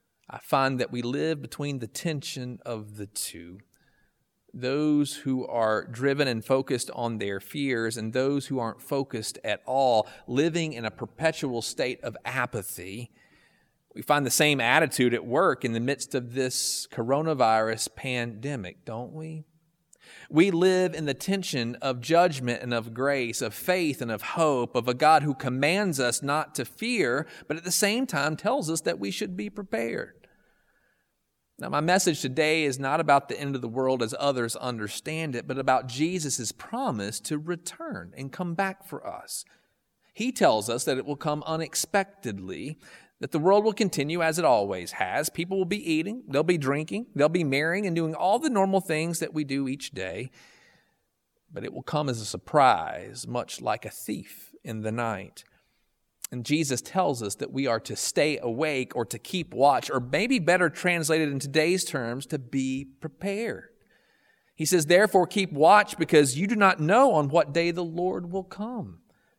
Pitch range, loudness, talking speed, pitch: 125-165 Hz, -26 LUFS, 180 wpm, 145 Hz